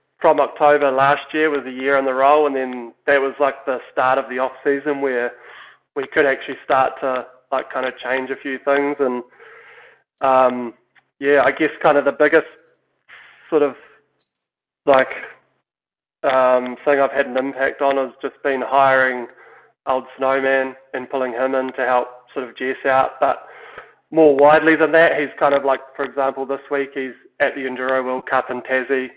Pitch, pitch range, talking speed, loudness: 135 Hz, 130-140 Hz, 185 wpm, -18 LUFS